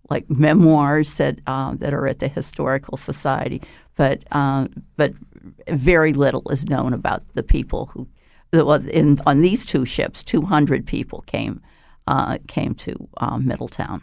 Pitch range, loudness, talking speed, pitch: 135-155 Hz, -20 LUFS, 150 wpm, 145 Hz